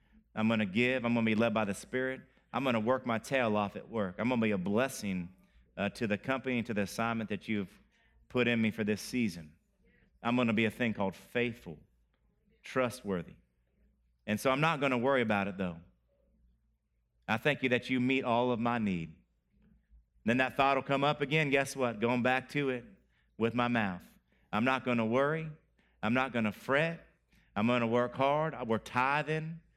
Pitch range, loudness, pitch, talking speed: 100-130 Hz, -32 LUFS, 115 Hz, 195 wpm